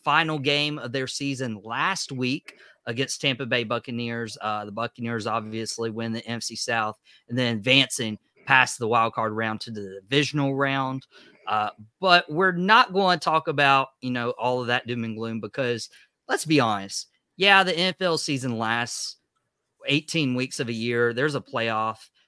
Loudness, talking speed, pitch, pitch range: -24 LUFS, 170 wpm, 120 Hz, 115-140 Hz